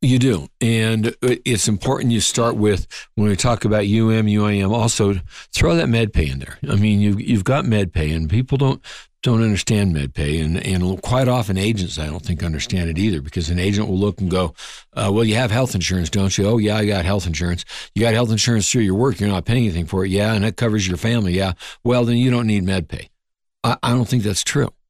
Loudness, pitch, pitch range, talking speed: -19 LUFS, 105 Hz, 95-115 Hz, 240 wpm